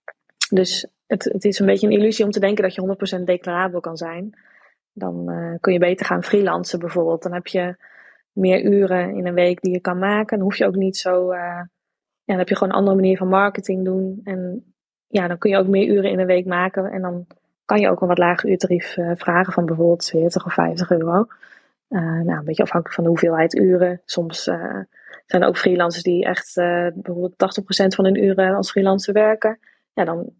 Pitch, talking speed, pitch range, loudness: 185 Hz, 220 wpm, 175-195 Hz, -19 LUFS